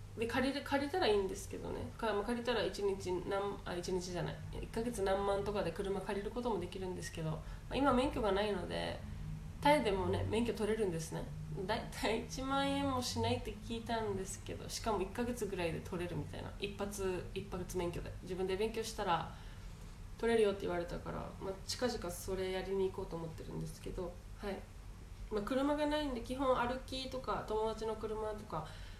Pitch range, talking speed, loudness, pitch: 180-240 Hz, 350 characters per minute, -38 LUFS, 205 Hz